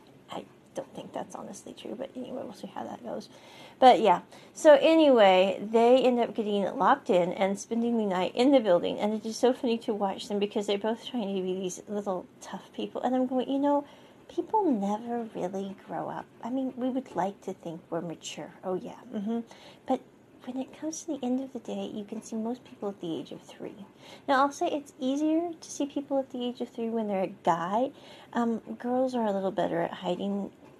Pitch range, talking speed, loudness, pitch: 200-260 Hz, 220 wpm, -28 LUFS, 230 Hz